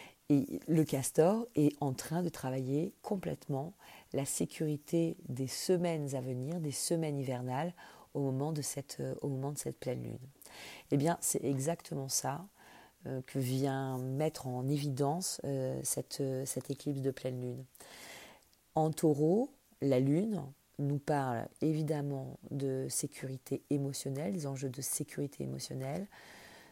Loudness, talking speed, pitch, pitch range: -35 LUFS, 135 wpm, 140 Hz, 130-155 Hz